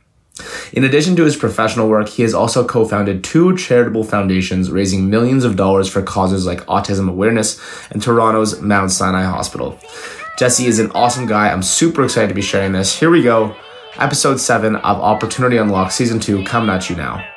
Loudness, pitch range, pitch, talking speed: -14 LUFS, 95-115 Hz, 110 Hz, 185 wpm